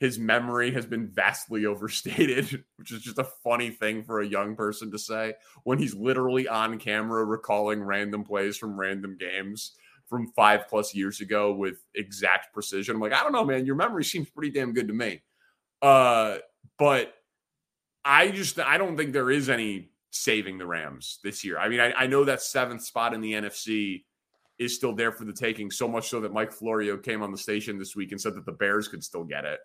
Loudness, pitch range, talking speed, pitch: -27 LUFS, 105-120 Hz, 210 wpm, 110 Hz